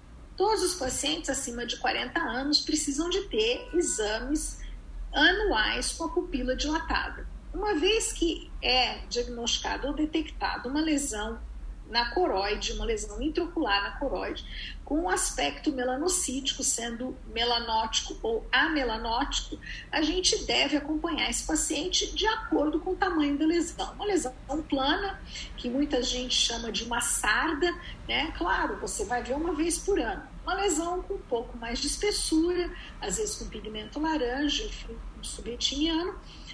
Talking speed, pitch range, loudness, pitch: 145 wpm, 245-350 Hz, -28 LUFS, 305 Hz